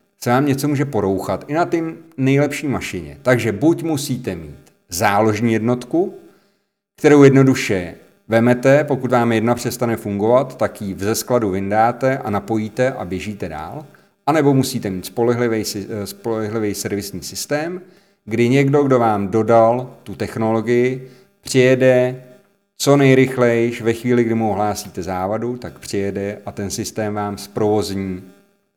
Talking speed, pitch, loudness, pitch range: 135 wpm, 115 Hz, -18 LUFS, 105-130 Hz